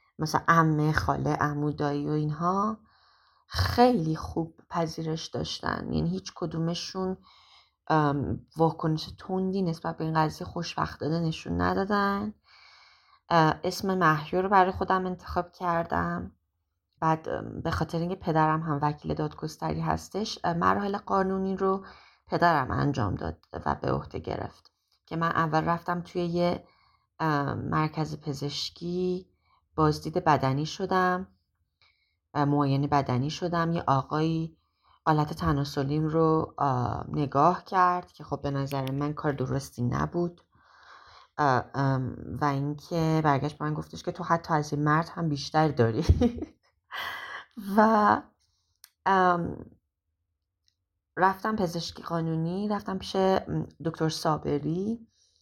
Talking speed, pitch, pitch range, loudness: 105 wpm, 160 Hz, 140-180 Hz, -28 LUFS